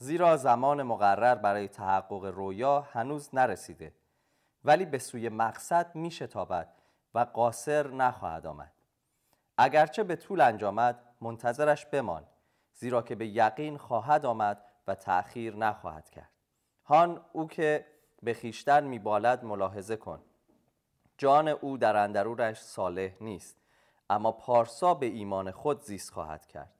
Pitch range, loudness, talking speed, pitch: 105-145 Hz, -29 LUFS, 125 wpm, 120 Hz